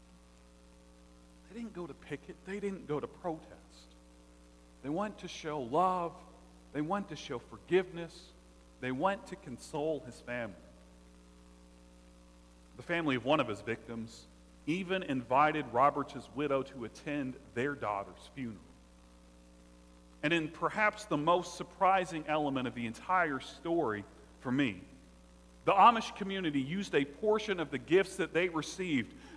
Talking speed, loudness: 135 wpm, -34 LUFS